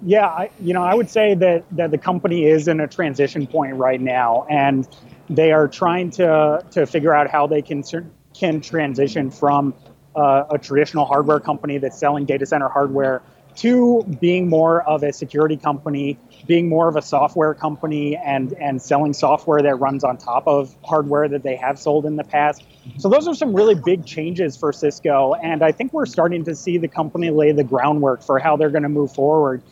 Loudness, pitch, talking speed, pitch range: -18 LUFS, 150 Hz, 200 wpm, 140-165 Hz